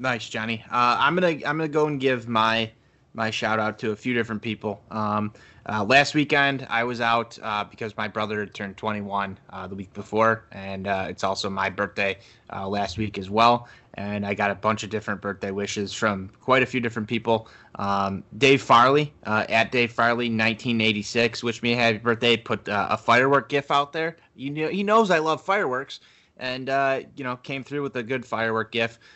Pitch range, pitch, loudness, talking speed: 105-125 Hz, 115 Hz, -24 LUFS, 210 wpm